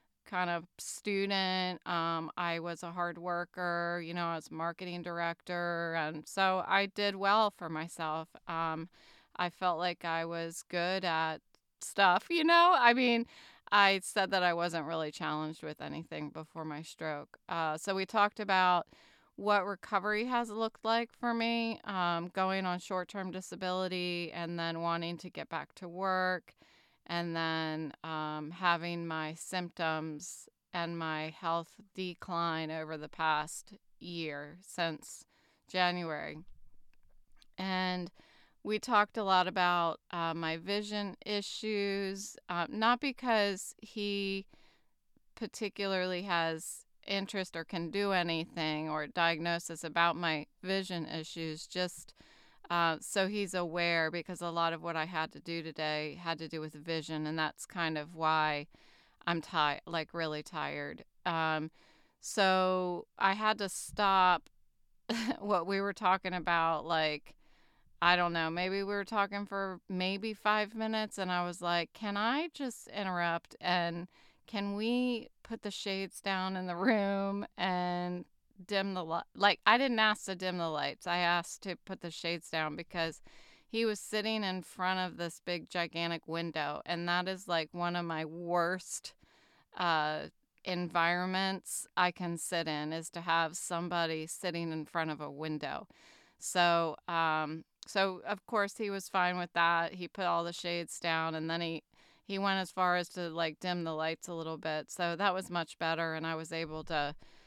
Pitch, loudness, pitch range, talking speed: 175 Hz, -34 LUFS, 165-195 Hz, 155 wpm